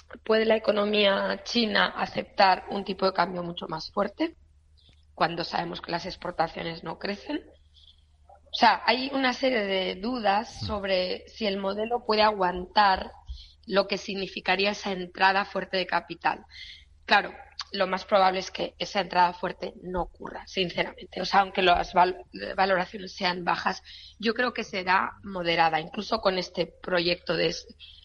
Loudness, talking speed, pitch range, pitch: -26 LUFS, 150 wpm, 175-200 Hz, 190 Hz